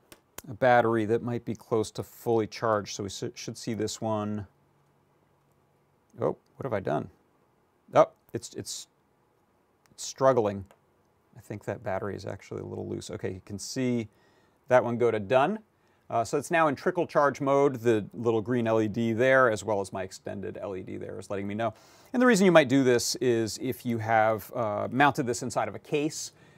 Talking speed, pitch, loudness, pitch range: 190 wpm, 115 Hz, -27 LUFS, 105-130 Hz